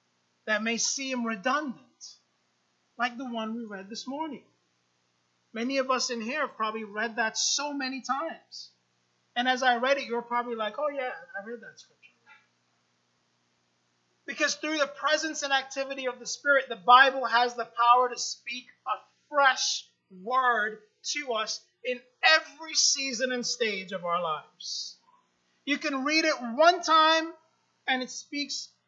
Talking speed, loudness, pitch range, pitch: 155 wpm, -27 LUFS, 215-275 Hz, 245 Hz